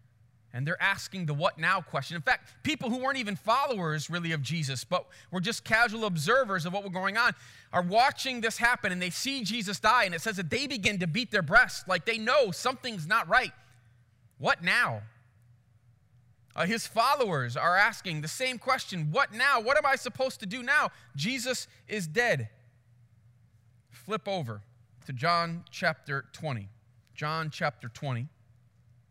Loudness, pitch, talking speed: -28 LUFS, 170 Hz, 170 wpm